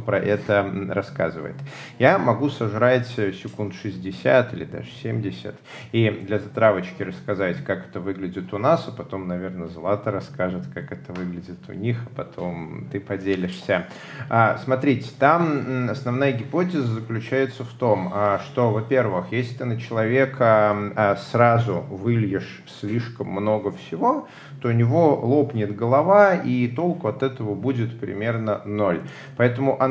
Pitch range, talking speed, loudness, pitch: 100-130 Hz, 130 wpm, -23 LUFS, 115 Hz